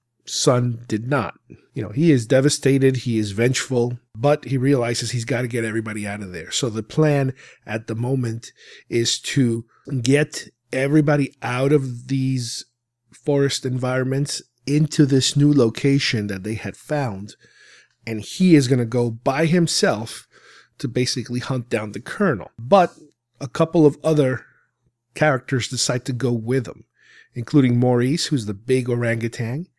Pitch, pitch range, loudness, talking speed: 130 Hz, 120-145 Hz, -21 LUFS, 155 wpm